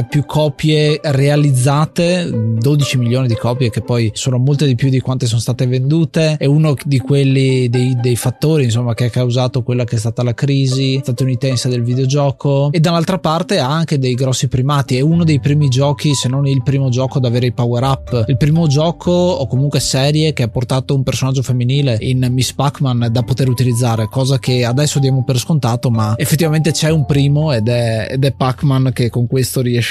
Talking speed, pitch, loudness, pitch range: 200 wpm, 135 Hz, -14 LUFS, 125-145 Hz